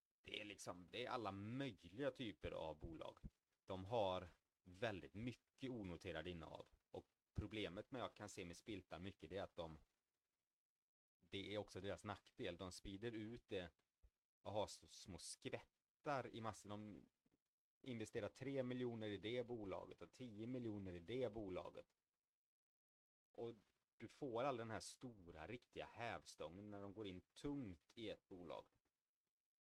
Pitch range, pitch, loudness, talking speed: 95-120 Hz, 105 Hz, -52 LUFS, 150 wpm